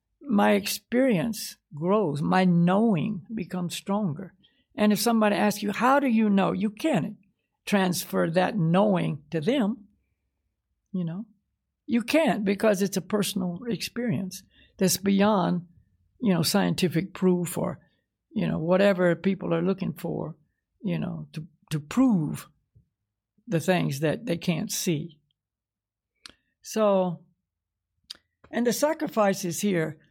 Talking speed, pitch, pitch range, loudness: 125 wpm, 190 Hz, 165-210 Hz, -25 LUFS